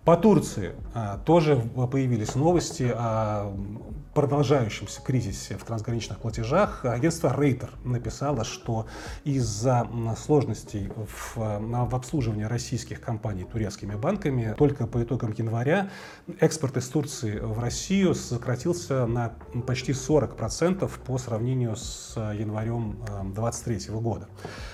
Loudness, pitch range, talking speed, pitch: -27 LUFS, 110-140 Hz, 100 wpm, 120 Hz